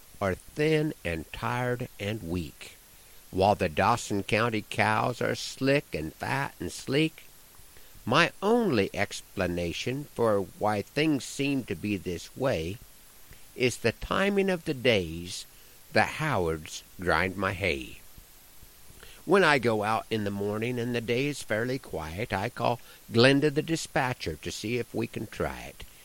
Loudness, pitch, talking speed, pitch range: -28 LUFS, 110 Hz, 145 wpm, 95-135 Hz